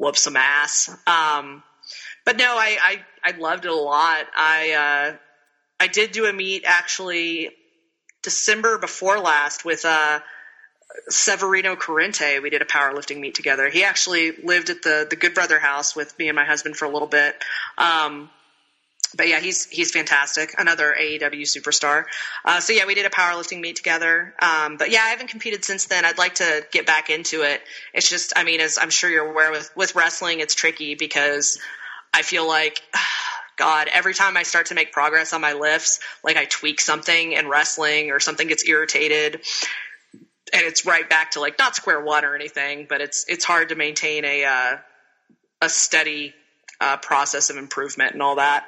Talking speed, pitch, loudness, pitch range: 185 wpm, 155 Hz, -19 LUFS, 150-175 Hz